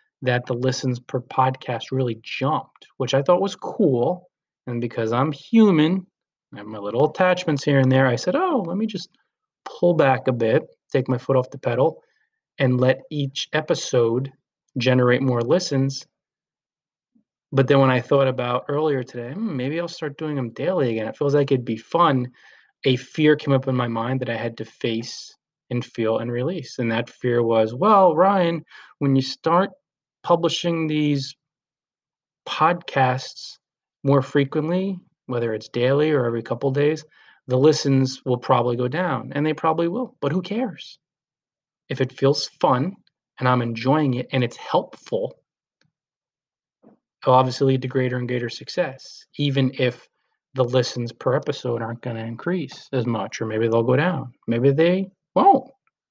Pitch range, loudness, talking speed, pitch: 125-160 Hz, -22 LUFS, 170 wpm, 135 Hz